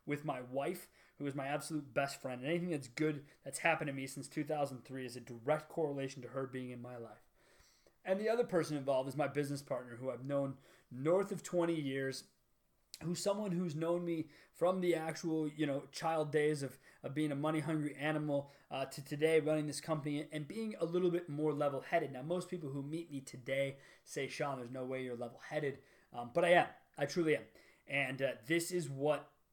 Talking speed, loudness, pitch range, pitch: 215 wpm, -38 LUFS, 135-165 Hz, 150 Hz